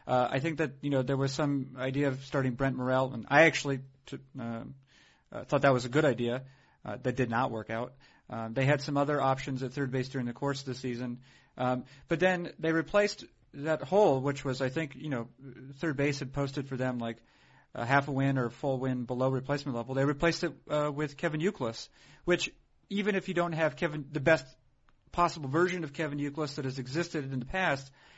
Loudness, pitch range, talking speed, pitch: -31 LUFS, 130-155 Hz, 225 wpm, 135 Hz